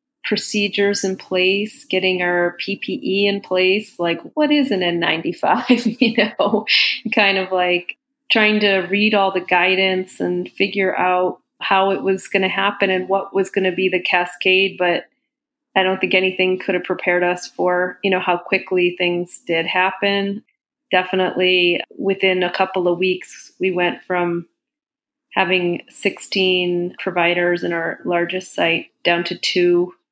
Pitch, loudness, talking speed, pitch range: 190 Hz, -18 LUFS, 155 wpm, 180-205 Hz